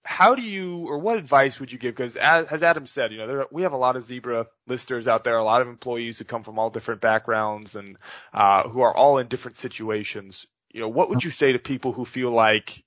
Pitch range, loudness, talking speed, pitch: 110-135 Hz, -23 LUFS, 255 wpm, 125 Hz